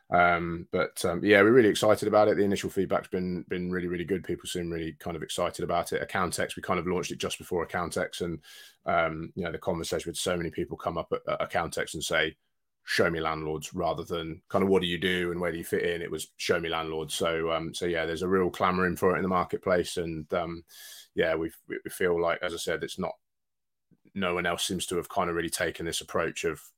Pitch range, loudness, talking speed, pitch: 80-90 Hz, -29 LUFS, 250 wpm, 85 Hz